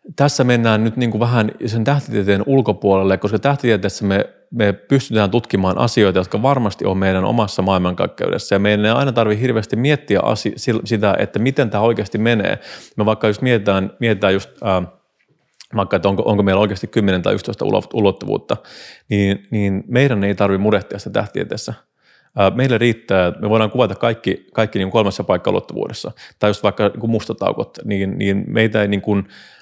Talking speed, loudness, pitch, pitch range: 170 wpm, -17 LUFS, 105 Hz, 100-115 Hz